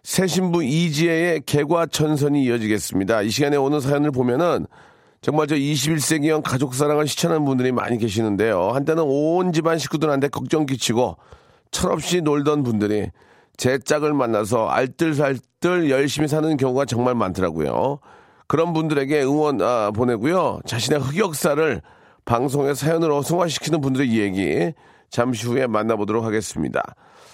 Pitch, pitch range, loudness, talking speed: 145 Hz, 120-155 Hz, -20 LUFS, 340 characters per minute